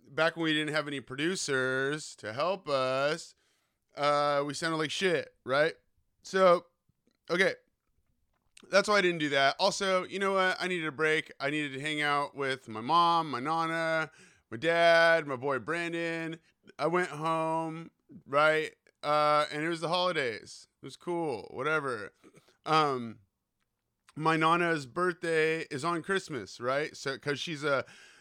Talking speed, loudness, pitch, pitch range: 155 wpm, -29 LUFS, 160 Hz, 145-170 Hz